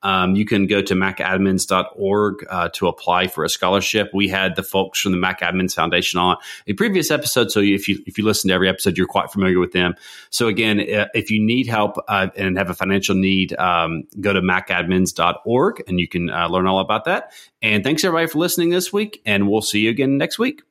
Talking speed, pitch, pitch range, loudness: 220 wpm, 100 Hz, 95-110 Hz, -18 LUFS